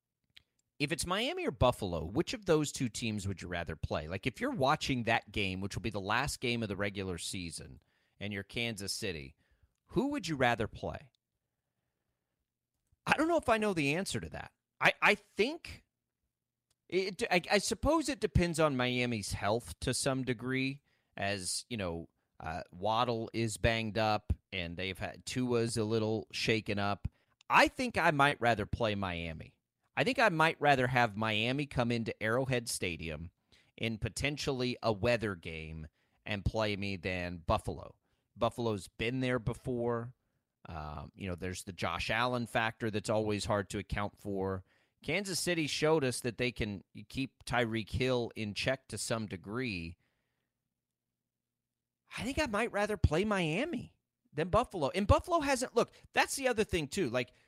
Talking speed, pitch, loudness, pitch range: 165 wpm, 115 Hz, -33 LUFS, 100-140 Hz